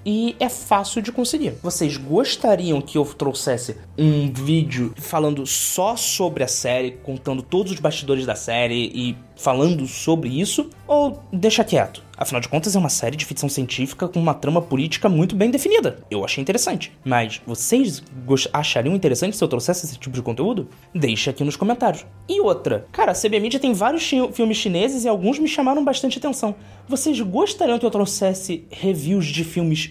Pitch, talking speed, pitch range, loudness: 170 Hz, 175 wpm, 135-225 Hz, -21 LUFS